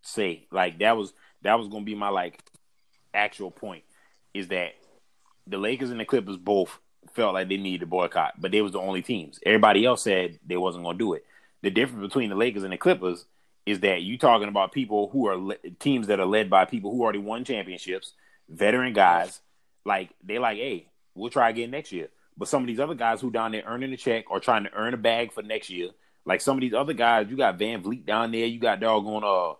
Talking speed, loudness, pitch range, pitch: 235 wpm, -26 LUFS, 95-120 Hz, 110 Hz